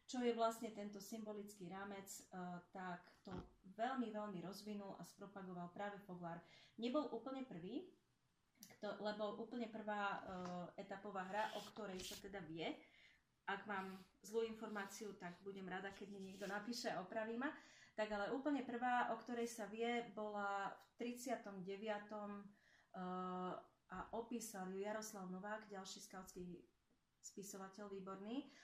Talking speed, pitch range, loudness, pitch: 140 wpm, 190-225 Hz, -49 LUFS, 205 Hz